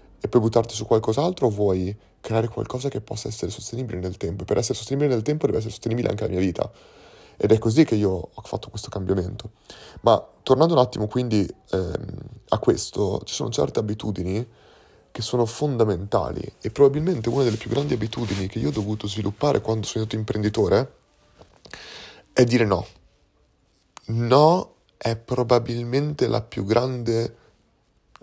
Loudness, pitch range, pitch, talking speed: -23 LUFS, 105-125 Hz, 115 Hz, 165 wpm